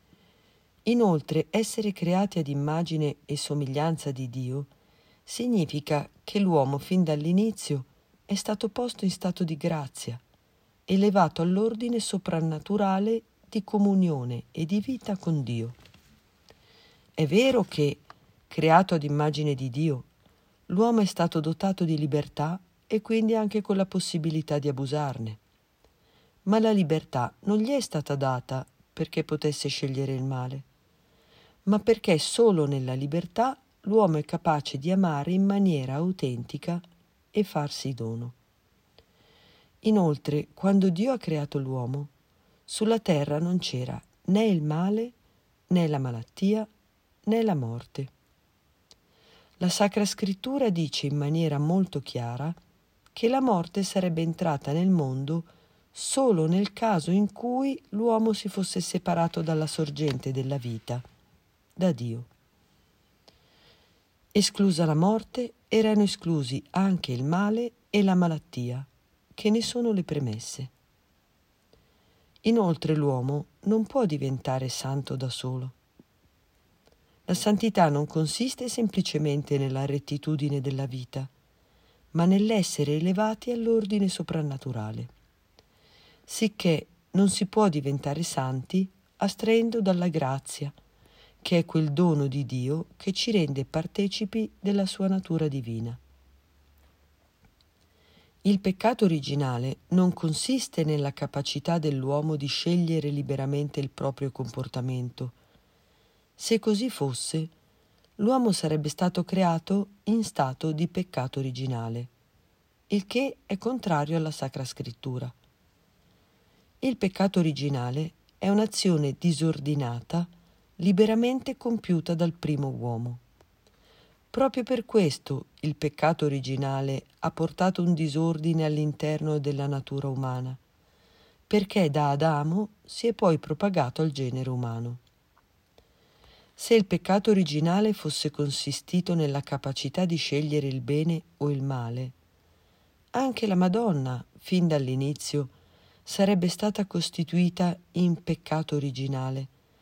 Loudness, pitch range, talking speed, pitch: -27 LUFS, 140-195 Hz, 115 wpm, 160 Hz